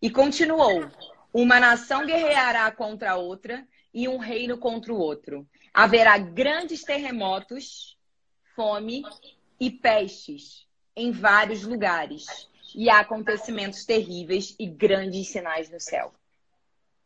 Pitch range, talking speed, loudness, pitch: 195-250 Hz, 115 wpm, -22 LUFS, 225 Hz